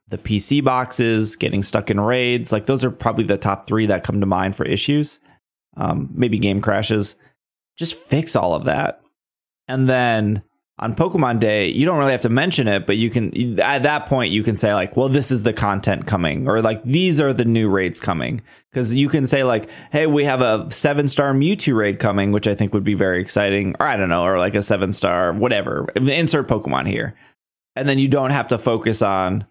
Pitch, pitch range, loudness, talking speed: 115 Hz, 100-135 Hz, -18 LUFS, 220 wpm